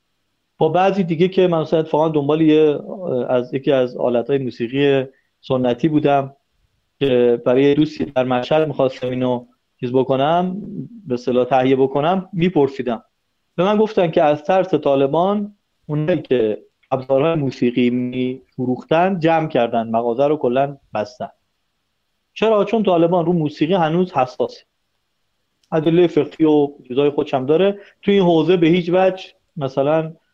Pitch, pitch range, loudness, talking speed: 150 Hz, 130-175 Hz, -18 LUFS, 135 wpm